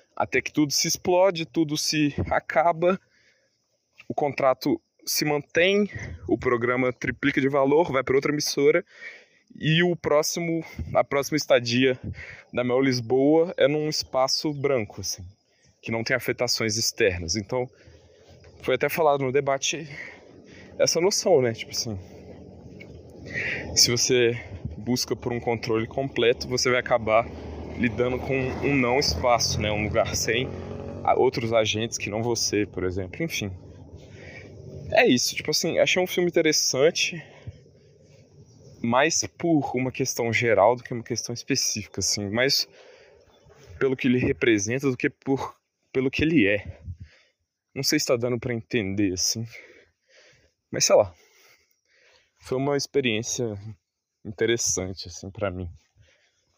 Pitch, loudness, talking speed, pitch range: 125 Hz, -24 LUFS, 135 wpm, 110-145 Hz